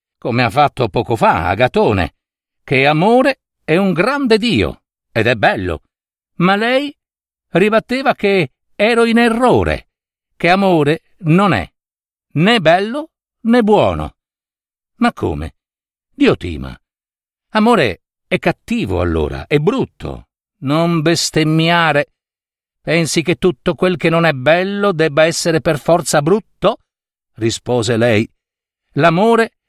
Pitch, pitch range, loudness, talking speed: 170 Hz, 150-215 Hz, -15 LUFS, 115 wpm